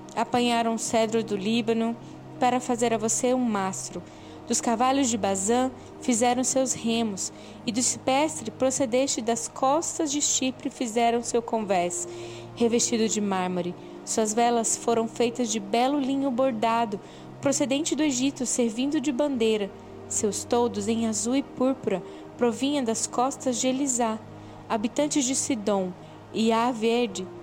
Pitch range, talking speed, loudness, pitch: 225-265 Hz, 140 wpm, -25 LUFS, 240 Hz